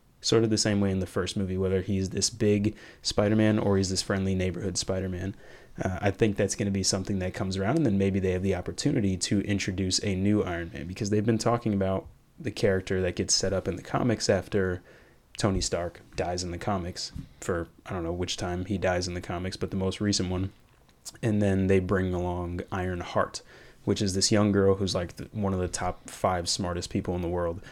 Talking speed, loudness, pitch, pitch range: 235 wpm, -28 LUFS, 95 Hz, 90-105 Hz